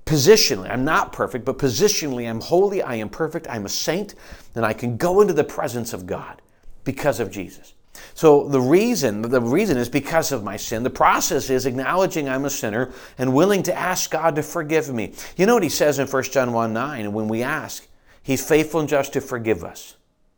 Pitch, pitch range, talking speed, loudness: 135 Hz, 120-160 Hz, 210 wpm, -20 LUFS